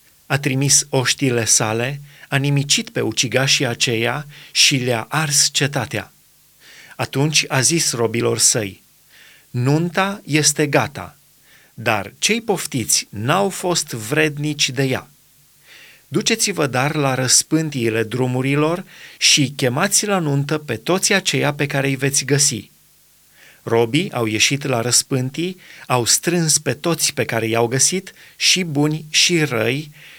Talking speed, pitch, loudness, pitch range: 125 wpm, 140 Hz, -17 LUFS, 125-155 Hz